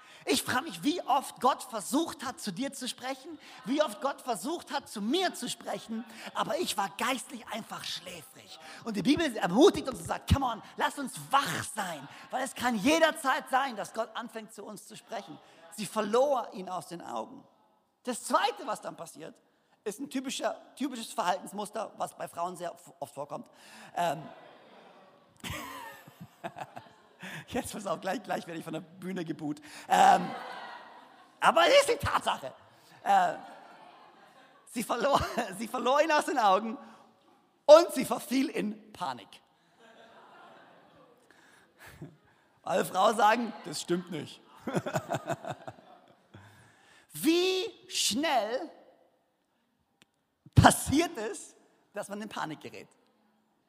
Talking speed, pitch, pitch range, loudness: 135 wpm, 245 Hz, 210-285 Hz, -30 LUFS